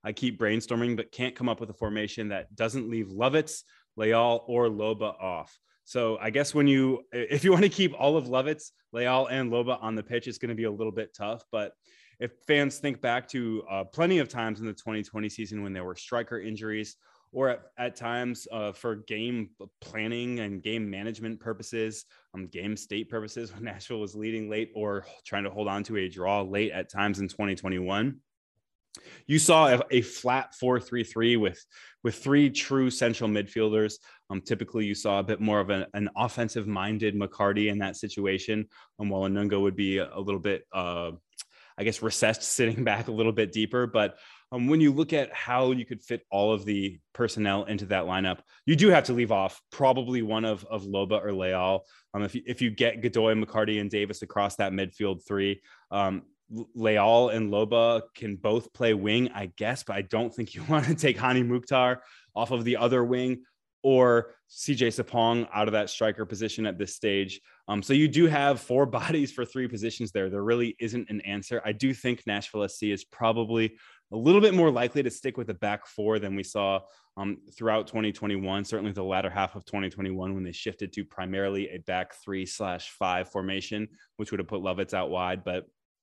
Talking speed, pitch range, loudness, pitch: 200 wpm, 100-120 Hz, -28 LUFS, 110 Hz